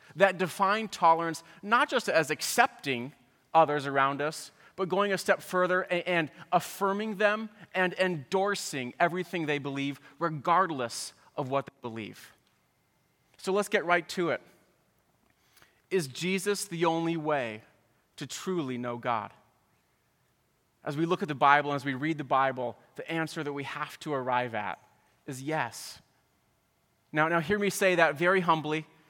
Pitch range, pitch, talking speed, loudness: 140-185 Hz, 165 Hz, 150 wpm, -29 LUFS